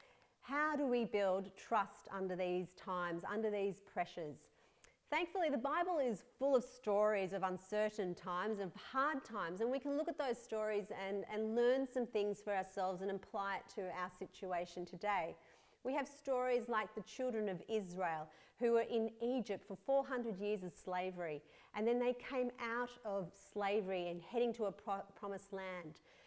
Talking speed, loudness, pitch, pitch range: 175 wpm, -41 LUFS, 210 Hz, 190-245 Hz